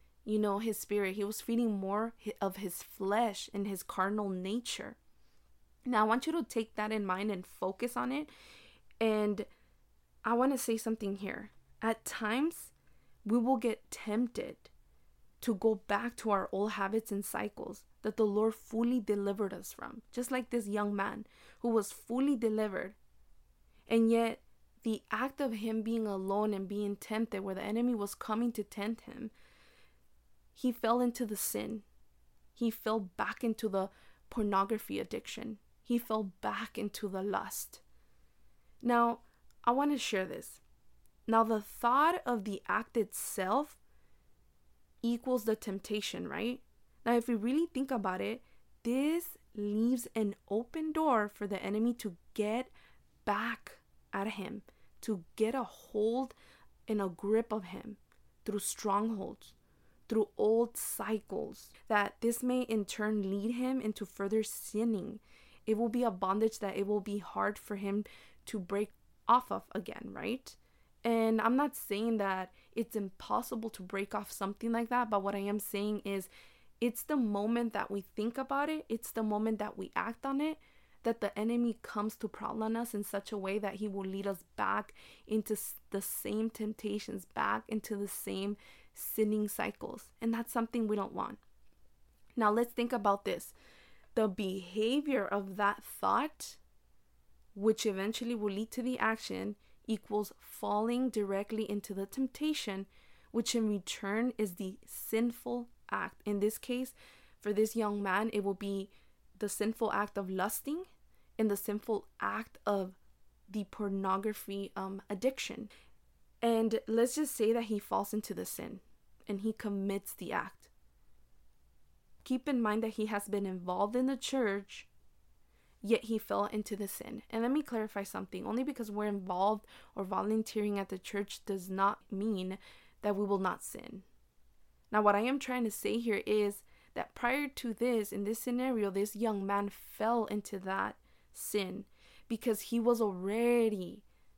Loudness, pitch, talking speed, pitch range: -35 LUFS, 215 Hz, 160 wpm, 200-235 Hz